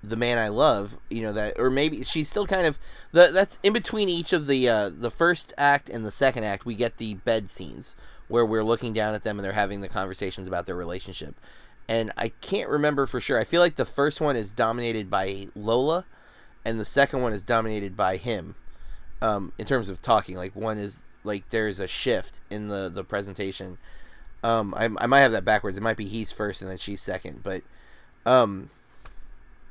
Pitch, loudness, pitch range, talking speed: 110 Hz, -25 LUFS, 100-130 Hz, 210 wpm